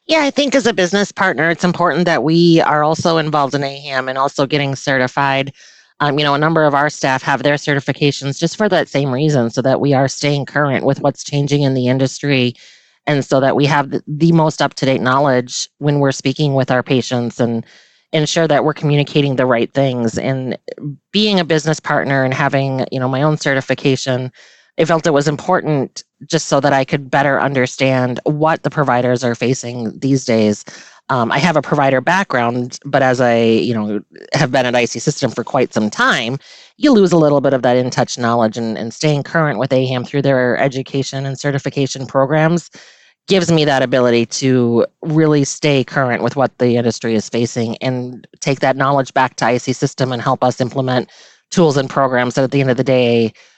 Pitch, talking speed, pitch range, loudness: 135 Hz, 205 wpm, 125-150 Hz, -15 LUFS